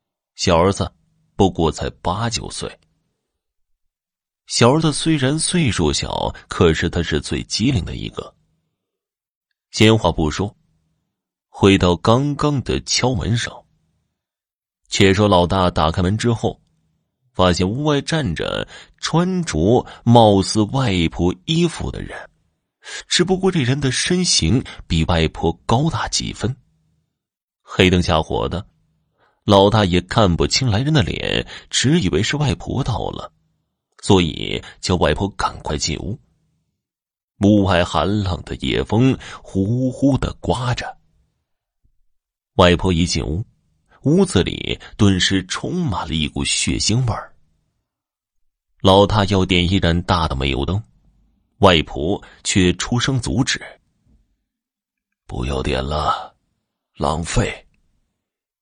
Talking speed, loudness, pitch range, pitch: 170 characters per minute, -18 LUFS, 85-130 Hz, 100 Hz